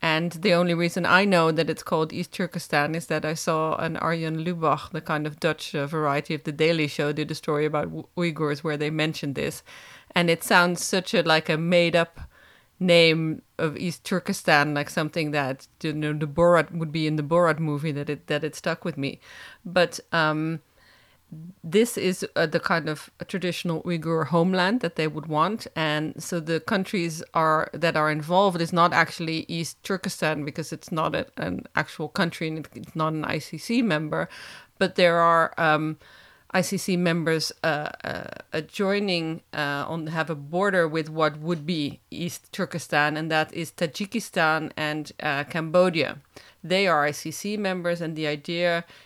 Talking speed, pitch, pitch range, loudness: 175 wpm, 165 Hz, 155-175 Hz, -25 LUFS